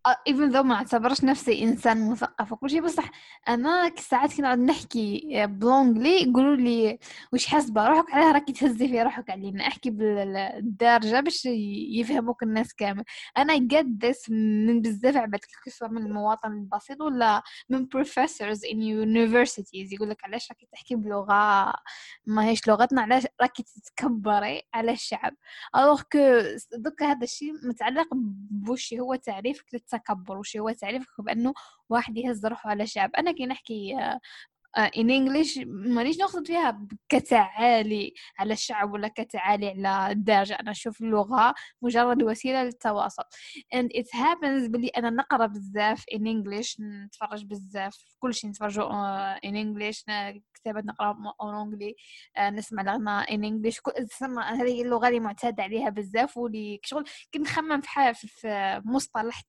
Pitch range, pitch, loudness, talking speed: 210-260 Hz, 235 Hz, -26 LUFS, 140 wpm